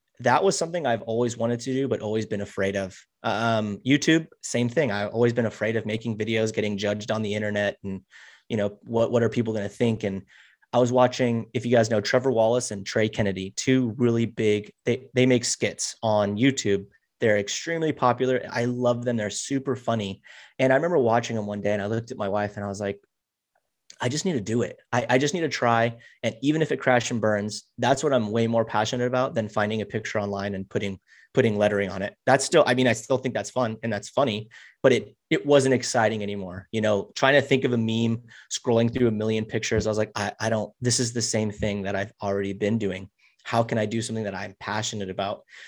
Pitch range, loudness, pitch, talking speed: 105-125 Hz, -25 LUFS, 115 Hz, 235 wpm